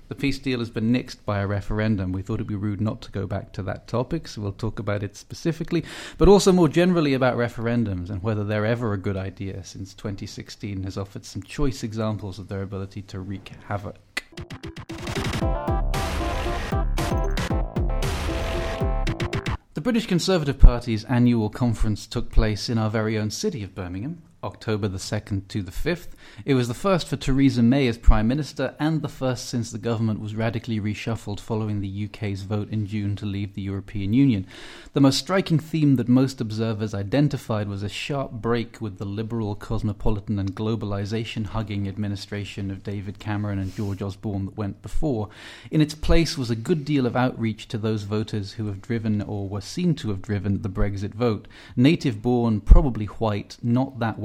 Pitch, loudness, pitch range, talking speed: 110 Hz, -25 LUFS, 100-125 Hz, 180 wpm